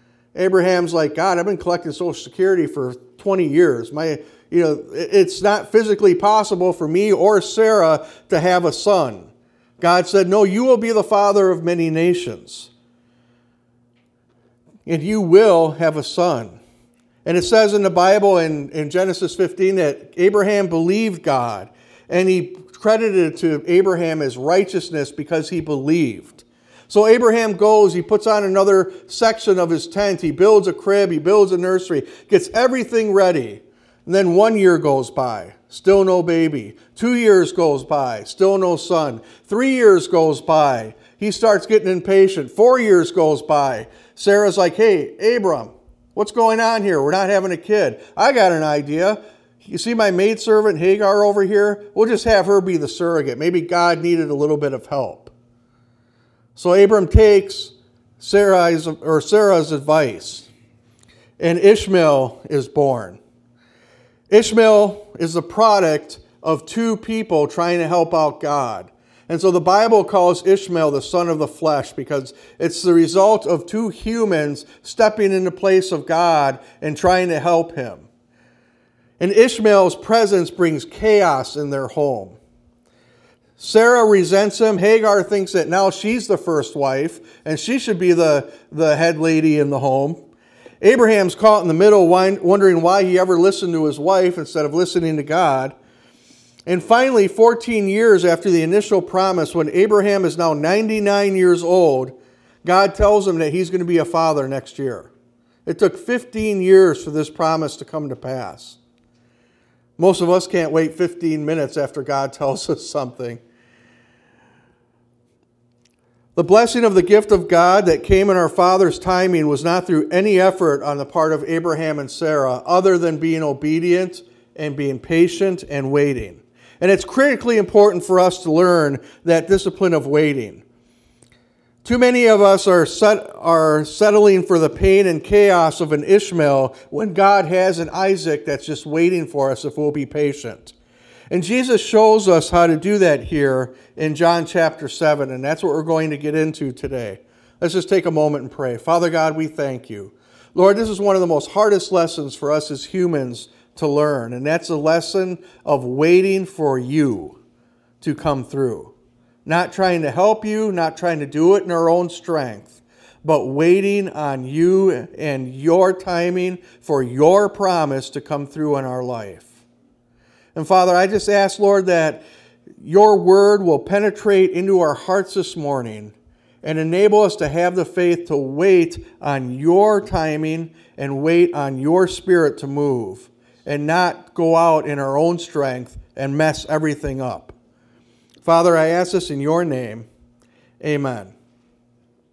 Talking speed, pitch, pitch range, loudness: 165 wpm, 170 Hz, 145-195 Hz, -16 LUFS